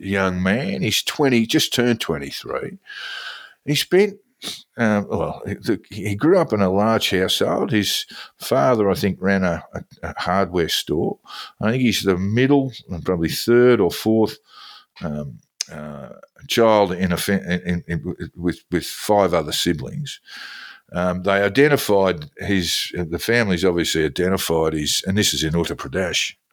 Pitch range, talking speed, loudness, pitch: 90-120 Hz, 150 wpm, -20 LUFS, 100 Hz